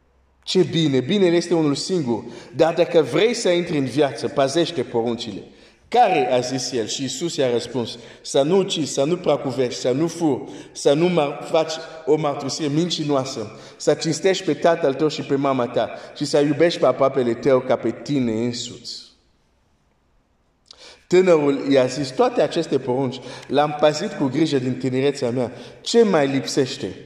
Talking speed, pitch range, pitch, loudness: 160 wpm, 125-160 Hz, 140 Hz, -20 LUFS